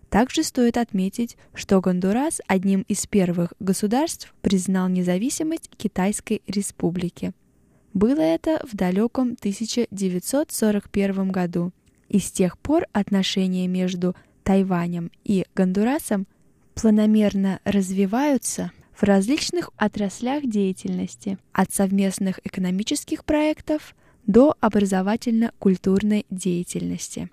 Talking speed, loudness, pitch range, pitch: 90 wpm, -23 LUFS, 190-235 Hz, 200 Hz